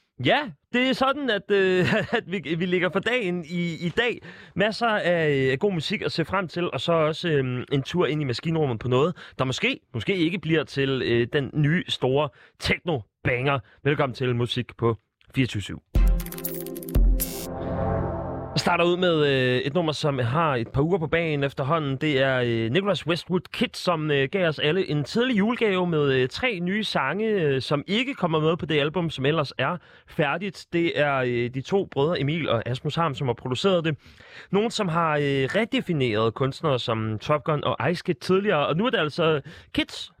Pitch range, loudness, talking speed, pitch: 135-180 Hz, -24 LUFS, 185 wpm, 155 Hz